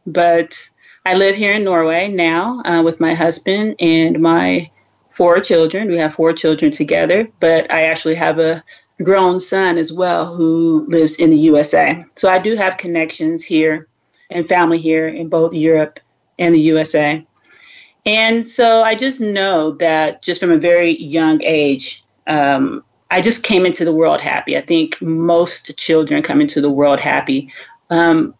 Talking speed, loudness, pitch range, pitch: 165 wpm, -14 LUFS, 160-185 Hz, 165 Hz